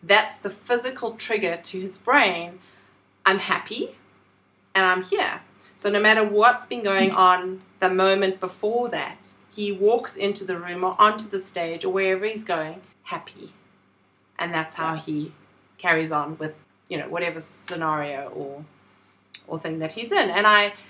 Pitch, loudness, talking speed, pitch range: 185 Hz, -23 LUFS, 160 wpm, 155-205 Hz